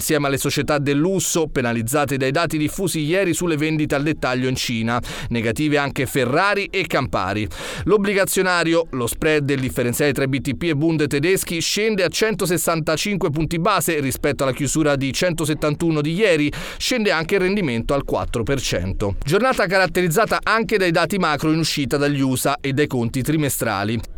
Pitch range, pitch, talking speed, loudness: 135-175 Hz, 150 Hz, 155 wpm, -20 LUFS